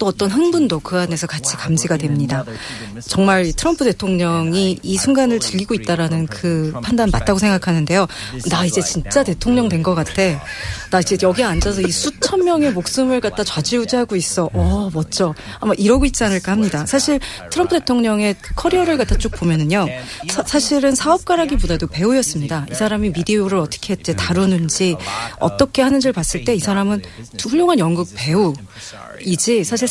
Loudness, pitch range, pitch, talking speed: -17 LUFS, 165-245 Hz, 190 Hz, 365 characters per minute